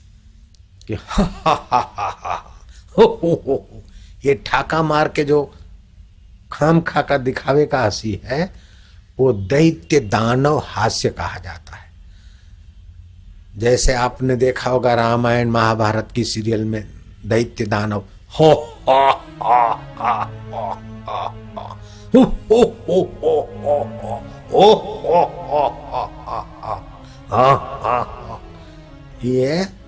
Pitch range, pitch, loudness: 95-135 Hz, 110 Hz, -18 LUFS